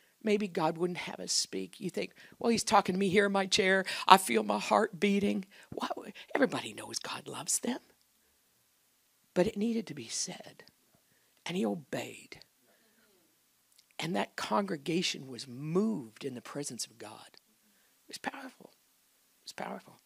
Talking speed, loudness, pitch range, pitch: 155 wpm, -32 LUFS, 155-205 Hz, 190 Hz